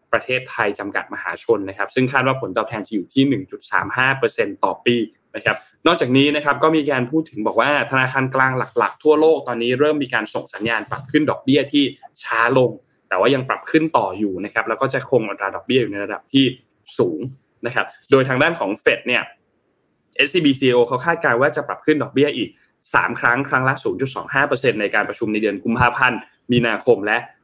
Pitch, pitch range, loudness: 130 Hz, 115-150 Hz, -19 LUFS